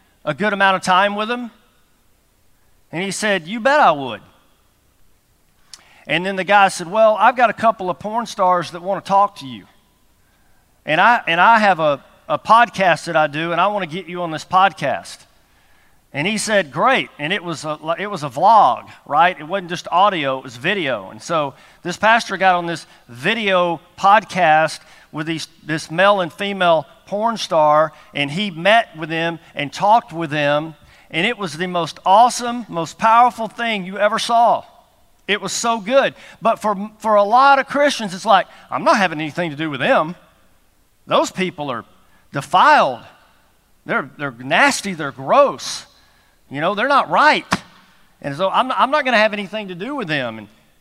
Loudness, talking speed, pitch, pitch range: -17 LUFS, 190 wpm, 185 Hz, 160-215 Hz